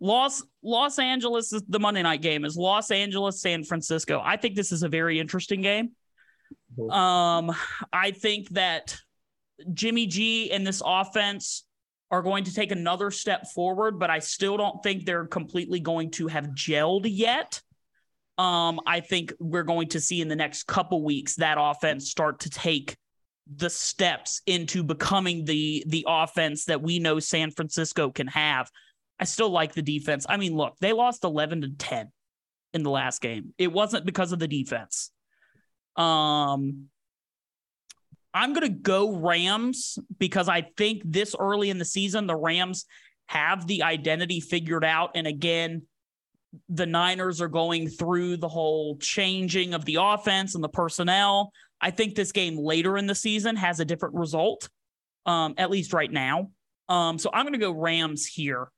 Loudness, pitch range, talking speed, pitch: -26 LUFS, 160-195 Hz, 170 wpm, 175 Hz